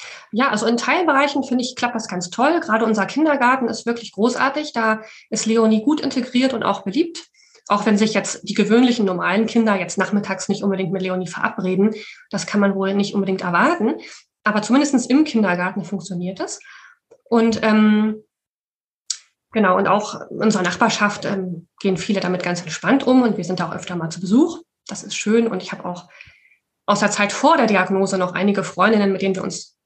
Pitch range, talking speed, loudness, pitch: 190-245 Hz, 190 wpm, -19 LUFS, 215 Hz